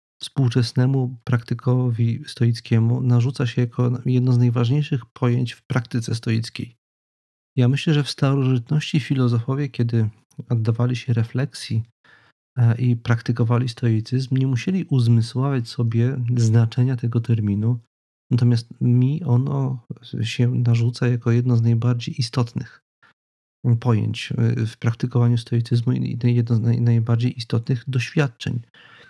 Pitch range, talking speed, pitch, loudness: 115-130 Hz, 110 wpm, 120 Hz, -21 LUFS